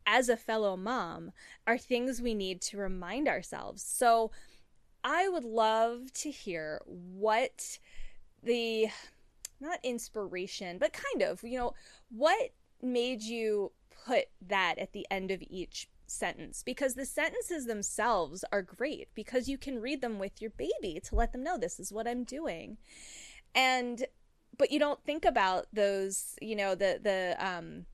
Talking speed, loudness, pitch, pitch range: 155 wpm, -33 LUFS, 230 Hz, 200-260 Hz